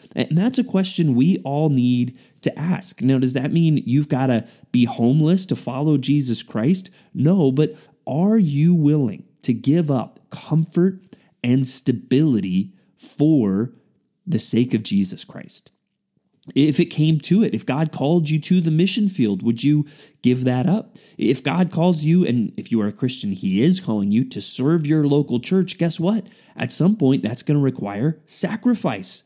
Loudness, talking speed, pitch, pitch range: -19 LUFS, 175 wpm, 155 Hz, 130-180 Hz